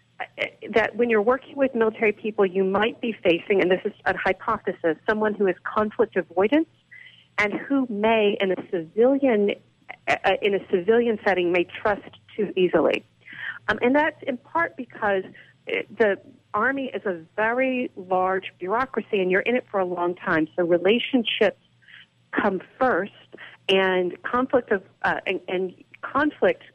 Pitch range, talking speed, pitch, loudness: 190-250 Hz, 155 wpm, 215 Hz, -23 LUFS